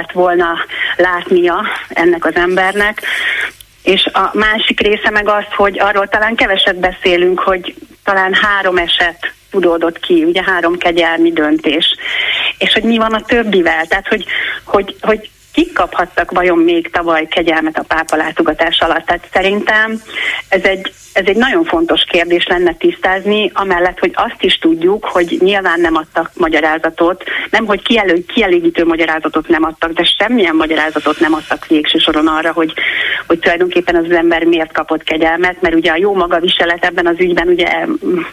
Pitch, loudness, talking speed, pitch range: 180 Hz, -12 LUFS, 160 wpm, 165-210 Hz